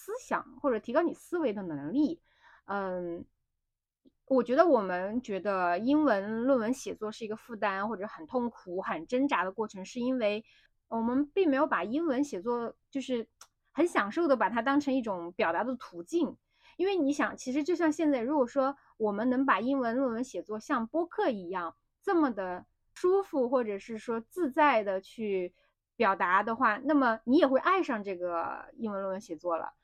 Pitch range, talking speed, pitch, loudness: 205-290 Hz, 265 characters per minute, 245 Hz, -30 LUFS